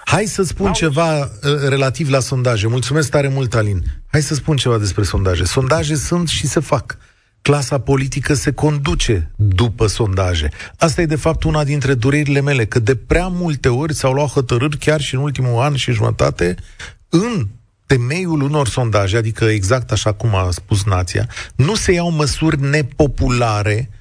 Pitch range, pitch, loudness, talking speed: 110-150 Hz, 135 Hz, -16 LUFS, 165 wpm